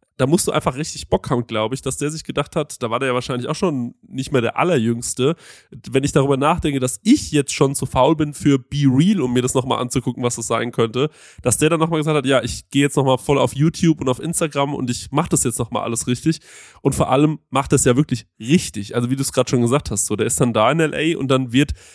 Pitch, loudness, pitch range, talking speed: 135 Hz, -19 LUFS, 125-155 Hz, 270 wpm